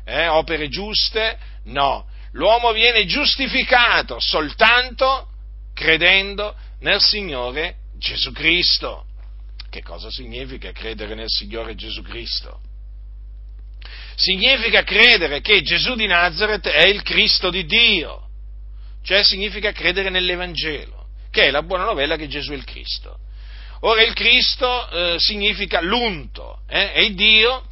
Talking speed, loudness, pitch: 120 wpm, -16 LUFS, 175 Hz